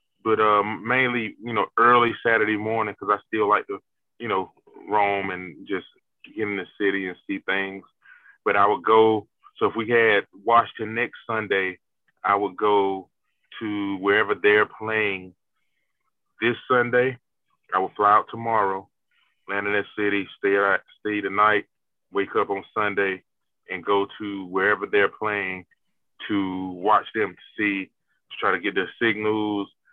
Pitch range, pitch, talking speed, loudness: 100-110 Hz, 105 Hz, 160 wpm, -23 LUFS